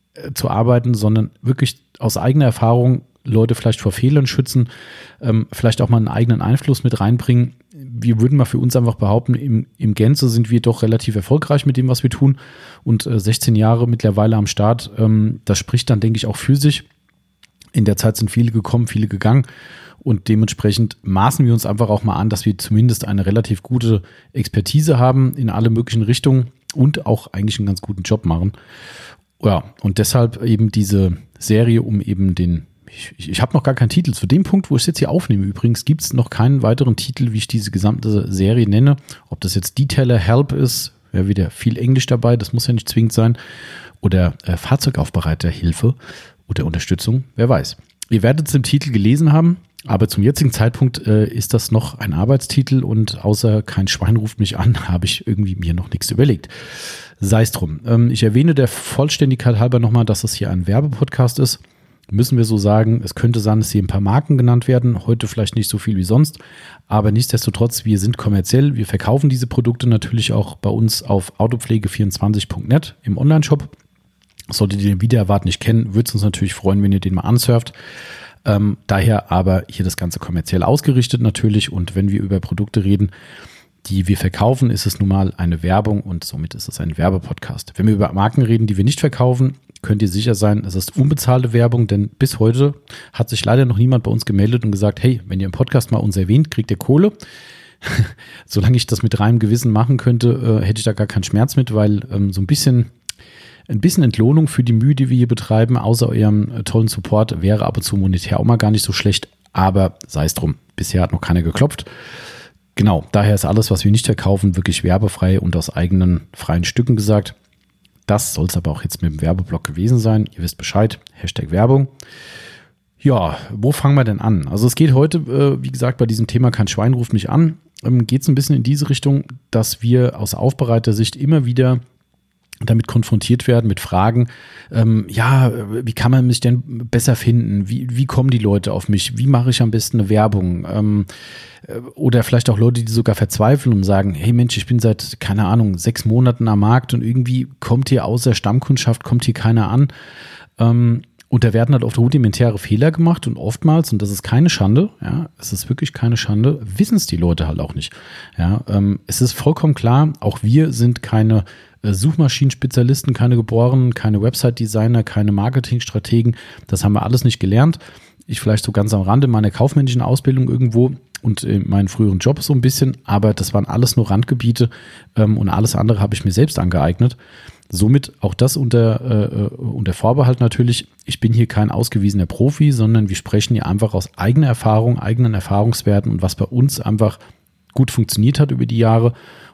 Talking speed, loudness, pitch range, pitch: 200 wpm, -16 LUFS, 105-125 Hz, 115 Hz